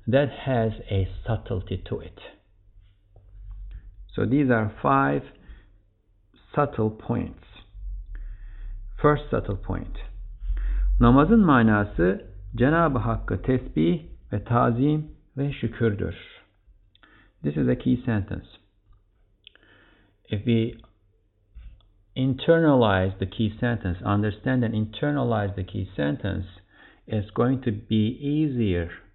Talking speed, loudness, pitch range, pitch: 95 wpm, -24 LUFS, 95-120 Hz, 105 Hz